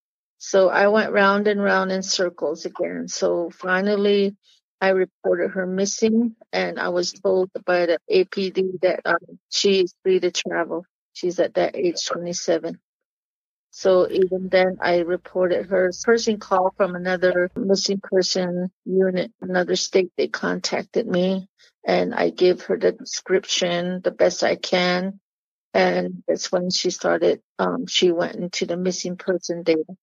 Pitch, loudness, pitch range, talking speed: 185 Hz, -21 LUFS, 180-195 Hz, 150 wpm